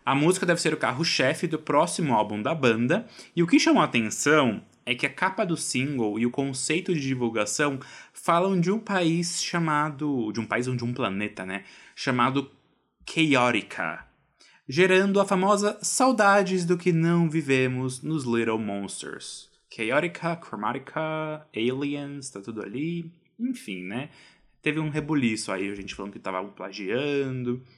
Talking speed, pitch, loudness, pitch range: 155 wpm, 145 Hz, -25 LUFS, 120-170 Hz